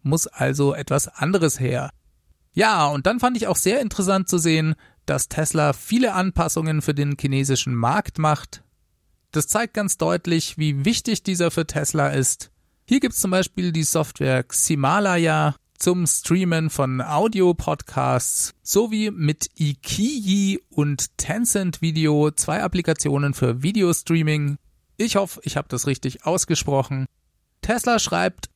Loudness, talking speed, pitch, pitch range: -21 LUFS, 135 wpm, 155 Hz, 135-185 Hz